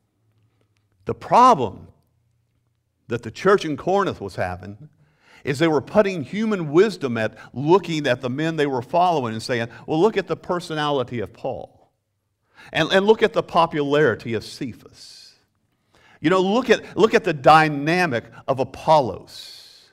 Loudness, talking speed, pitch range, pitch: -20 LUFS, 150 wpm, 115-175 Hz, 145 Hz